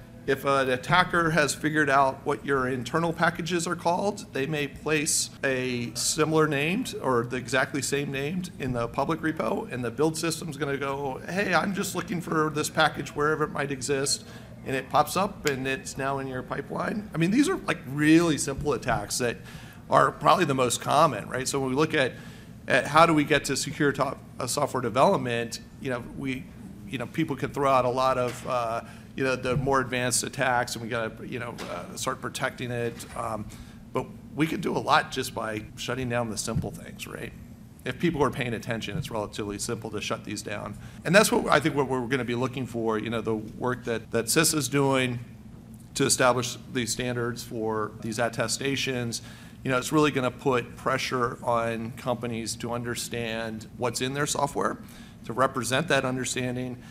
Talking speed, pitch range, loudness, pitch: 200 wpm, 120-150 Hz, -27 LUFS, 130 Hz